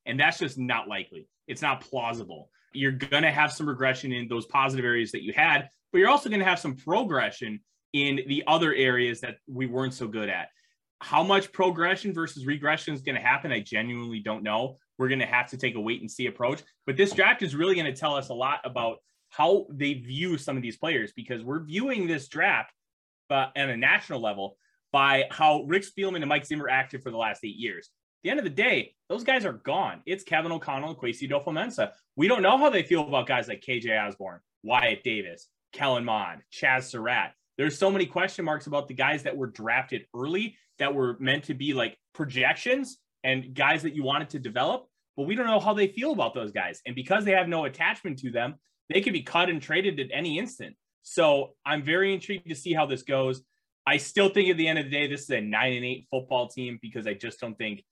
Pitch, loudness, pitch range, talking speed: 140 Hz, -27 LUFS, 125-170 Hz, 225 wpm